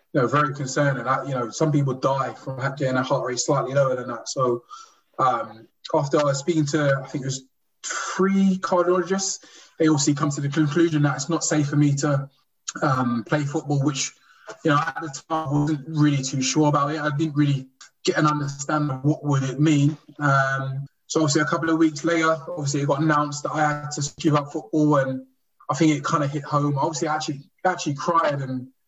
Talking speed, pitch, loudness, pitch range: 220 wpm, 150 Hz, -23 LUFS, 135-160 Hz